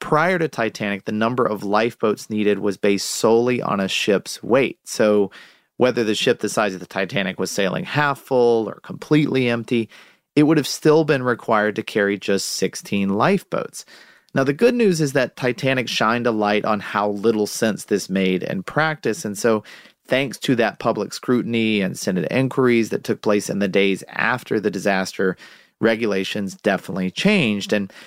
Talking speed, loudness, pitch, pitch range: 175 wpm, -20 LUFS, 110 Hz, 100-130 Hz